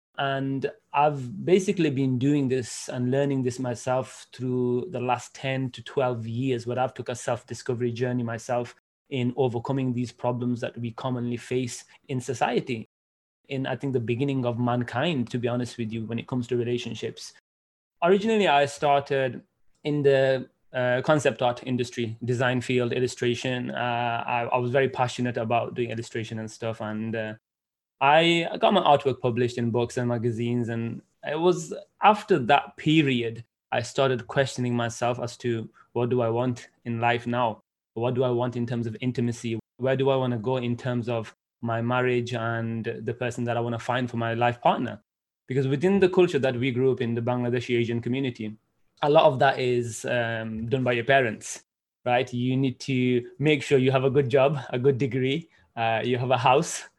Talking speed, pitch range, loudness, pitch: 185 wpm, 120-135 Hz, -26 LUFS, 125 Hz